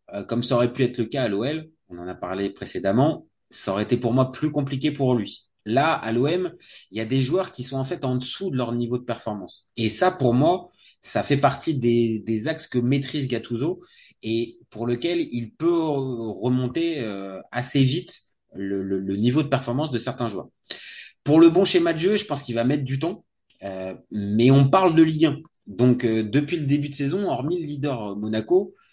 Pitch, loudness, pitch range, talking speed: 125 Hz, -23 LUFS, 115-150 Hz, 210 wpm